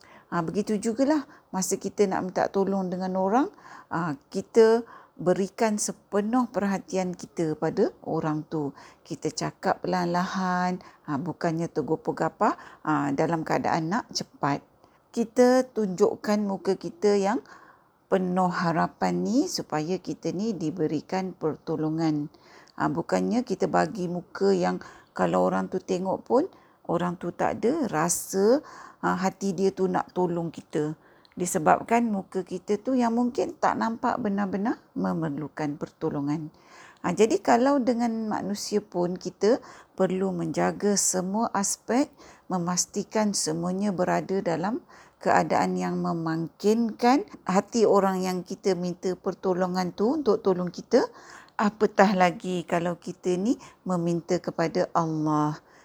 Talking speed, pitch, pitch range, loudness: 125 wpm, 185 Hz, 170-210 Hz, -26 LUFS